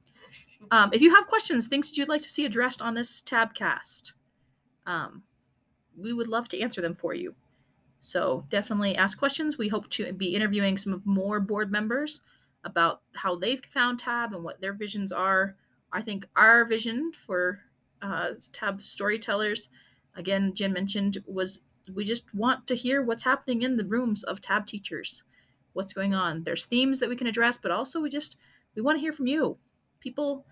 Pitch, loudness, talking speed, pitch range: 215 Hz, -27 LUFS, 185 wpm, 195-250 Hz